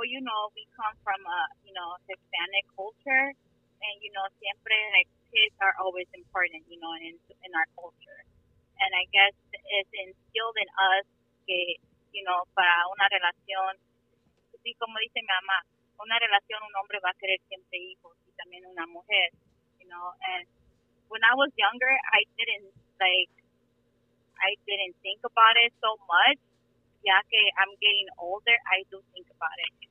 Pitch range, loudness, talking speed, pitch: 180-215 Hz, -25 LUFS, 165 wpm, 195 Hz